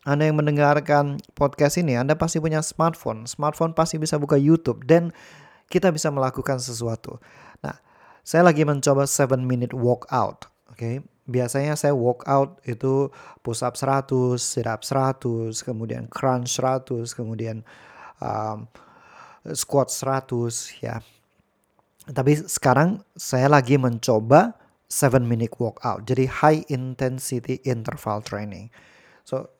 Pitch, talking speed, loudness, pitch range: 135 Hz, 130 wpm, -22 LUFS, 120-150 Hz